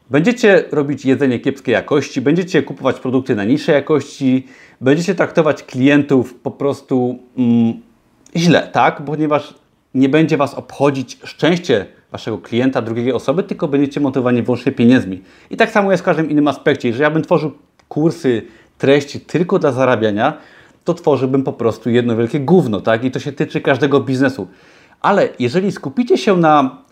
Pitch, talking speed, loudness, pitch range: 140 Hz, 155 wpm, -16 LUFS, 130-155 Hz